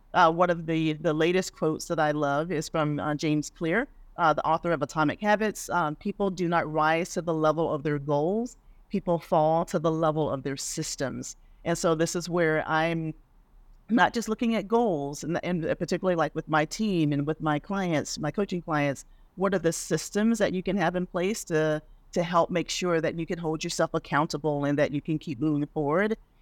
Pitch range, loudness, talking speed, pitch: 155-180 Hz, -27 LUFS, 210 wpm, 165 Hz